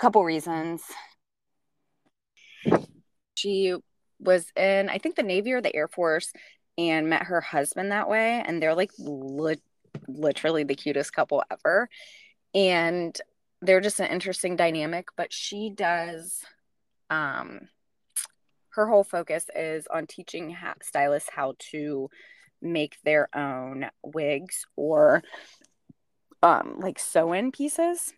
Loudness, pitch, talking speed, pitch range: -26 LUFS, 170 Hz, 120 wpm, 150-195 Hz